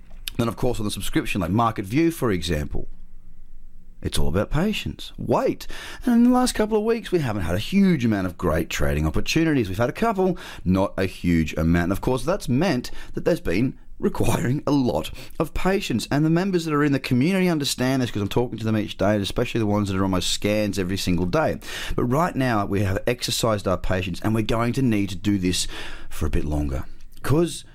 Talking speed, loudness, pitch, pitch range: 225 wpm, -23 LUFS, 110 Hz, 95-140 Hz